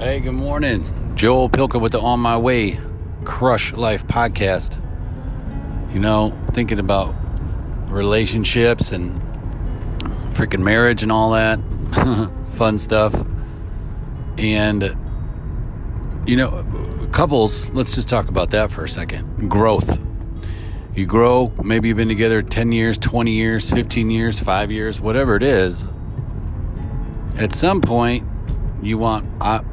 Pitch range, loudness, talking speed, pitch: 95-115 Hz, -19 LUFS, 125 wpm, 110 Hz